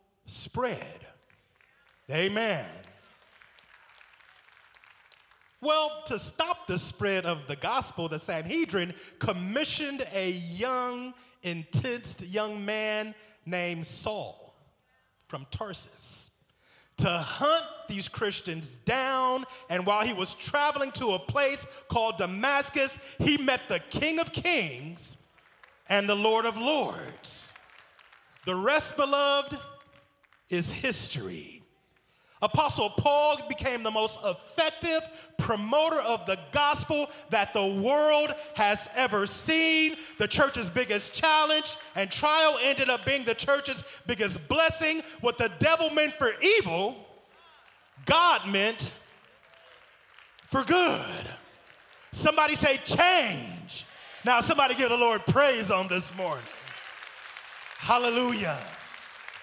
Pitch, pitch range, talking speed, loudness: 250 Hz, 200-295 Hz, 105 wpm, -27 LUFS